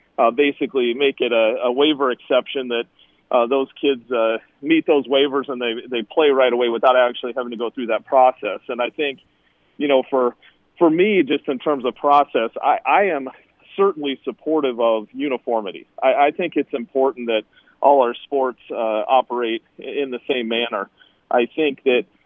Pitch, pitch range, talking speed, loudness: 130 Hz, 120-145 Hz, 185 wpm, -19 LUFS